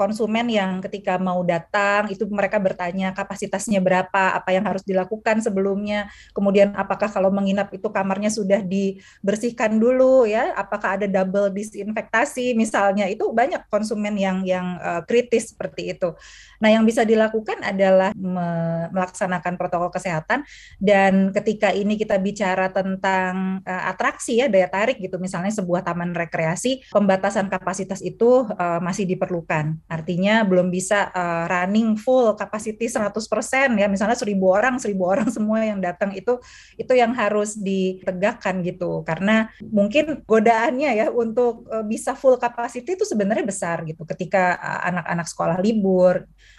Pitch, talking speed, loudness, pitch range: 200 Hz, 145 wpm, -21 LUFS, 185-220 Hz